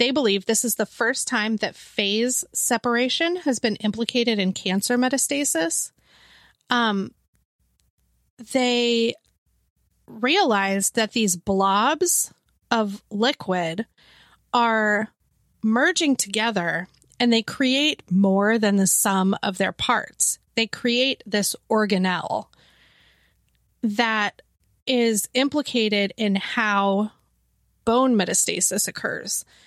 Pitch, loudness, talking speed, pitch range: 225 Hz, -22 LUFS, 100 wpm, 200-245 Hz